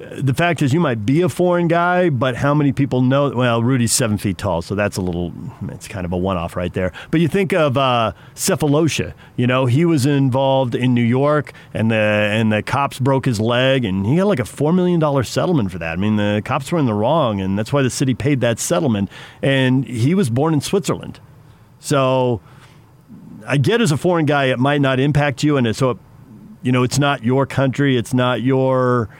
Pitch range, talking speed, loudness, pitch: 115-145 Hz, 220 wpm, -17 LUFS, 130 Hz